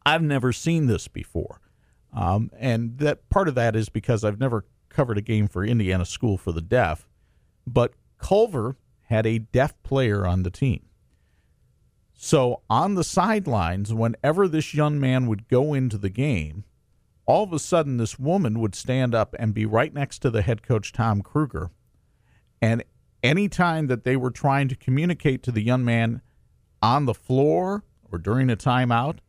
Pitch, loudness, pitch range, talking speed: 125 Hz, -23 LUFS, 110-145 Hz, 175 wpm